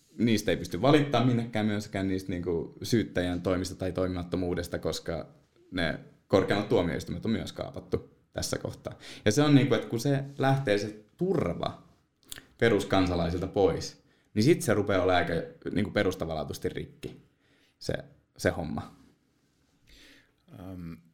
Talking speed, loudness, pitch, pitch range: 125 wpm, -29 LUFS, 95 Hz, 90-115 Hz